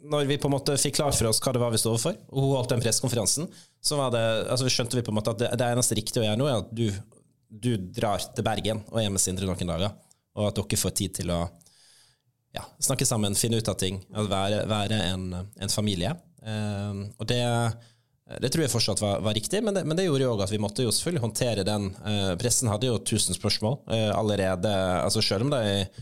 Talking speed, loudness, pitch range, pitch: 245 wpm, -26 LUFS, 100-125 Hz, 110 Hz